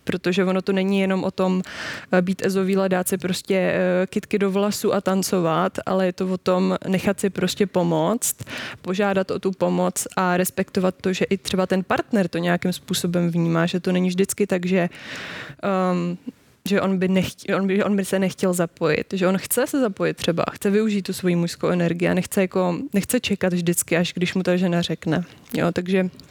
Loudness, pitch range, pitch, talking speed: -22 LUFS, 180-195 Hz, 185 Hz, 195 wpm